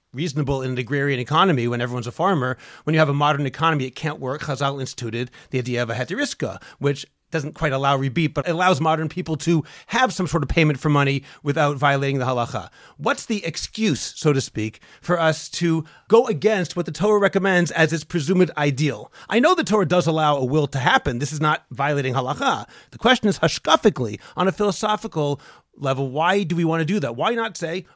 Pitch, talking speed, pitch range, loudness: 155 Hz, 215 wpm, 140-175 Hz, -21 LUFS